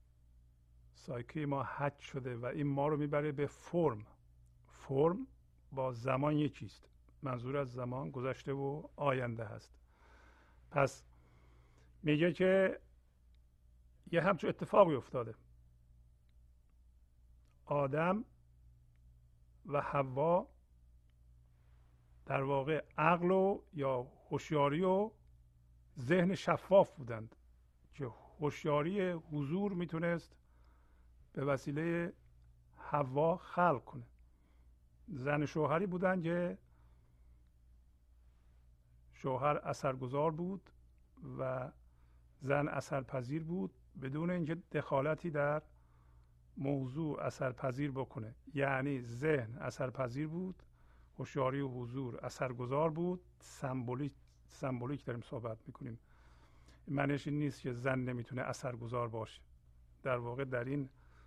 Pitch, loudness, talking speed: 125 Hz, -37 LUFS, 95 wpm